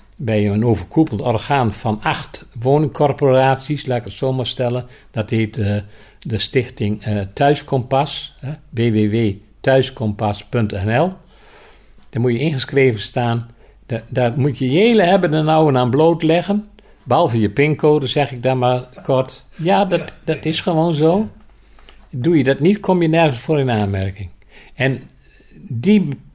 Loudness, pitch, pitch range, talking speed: -17 LUFS, 130 Hz, 110-155 Hz, 135 wpm